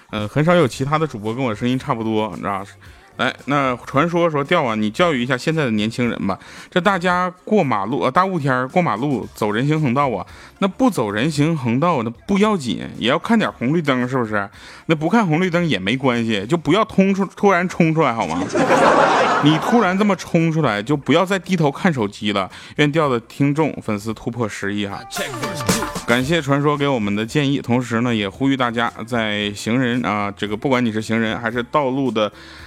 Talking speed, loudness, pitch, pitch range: 305 characters per minute, -19 LUFS, 135 Hz, 110-170 Hz